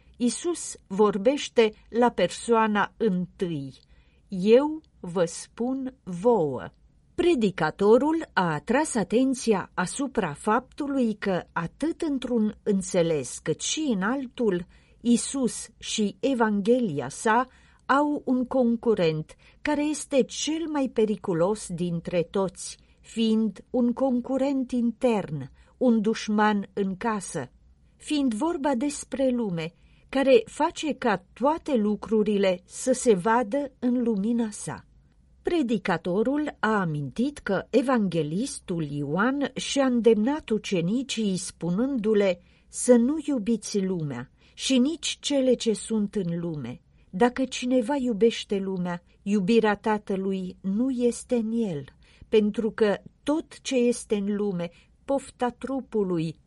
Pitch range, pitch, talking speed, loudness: 195-255 Hz, 225 Hz, 105 wpm, -26 LUFS